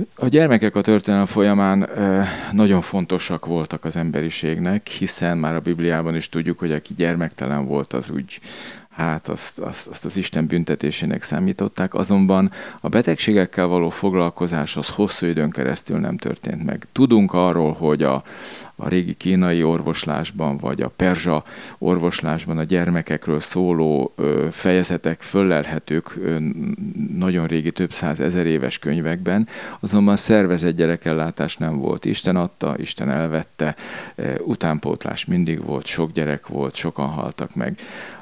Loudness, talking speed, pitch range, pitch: -21 LUFS, 140 wpm, 80-95 Hz, 85 Hz